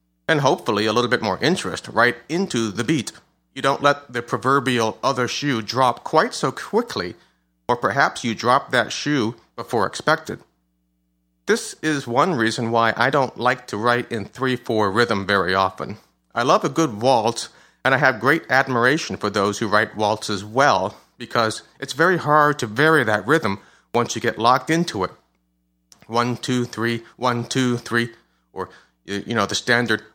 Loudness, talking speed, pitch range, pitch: -20 LUFS, 175 wpm, 105-130 Hz, 120 Hz